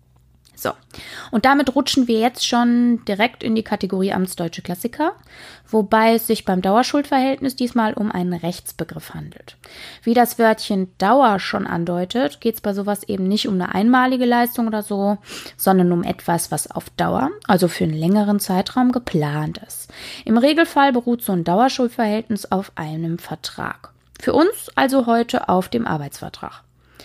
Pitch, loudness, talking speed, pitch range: 215 Hz, -19 LUFS, 155 wpm, 180-240 Hz